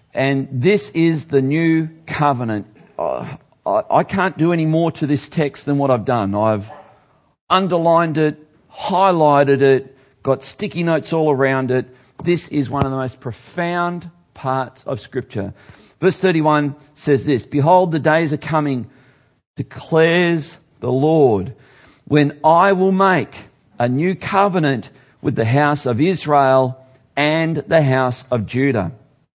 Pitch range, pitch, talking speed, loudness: 130-165 Hz, 145 Hz, 140 wpm, -17 LUFS